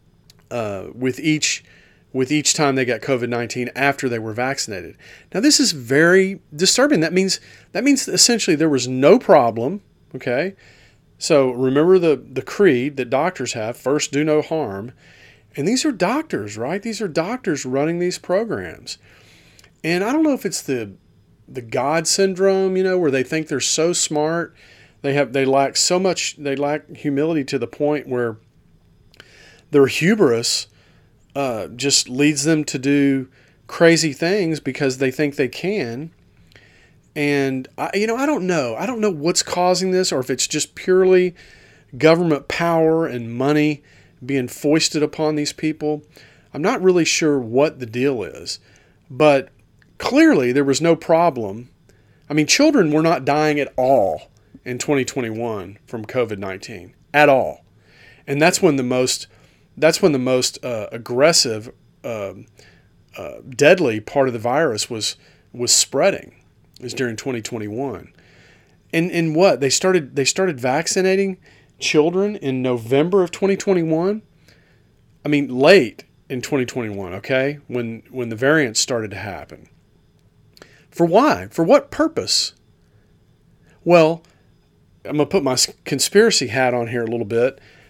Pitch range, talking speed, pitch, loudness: 125-170 Hz, 150 wpm, 145 Hz, -18 LUFS